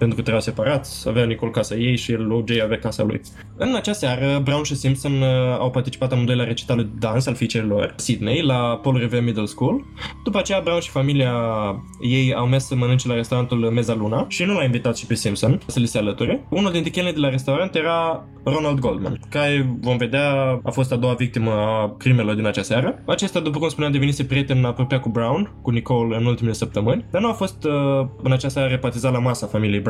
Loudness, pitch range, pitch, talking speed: -21 LUFS, 115-140 Hz, 125 Hz, 215 wpm